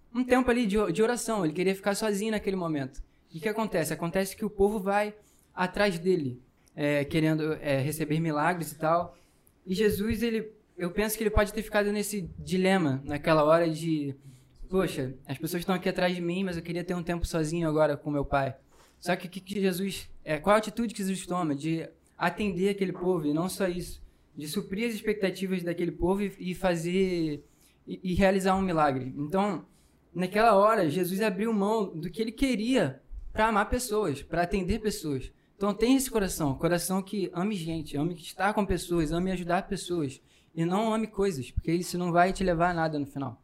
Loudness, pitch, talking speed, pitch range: -29 LUFS, 180 Hz, 200 wpm, 160-205 Hz